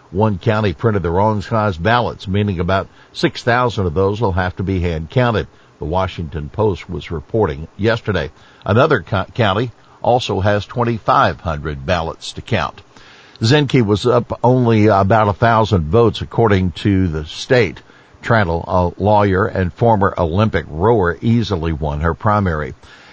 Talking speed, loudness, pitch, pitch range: 155 wpm, -16 LUFS, 100 Hz, 90-115 Hz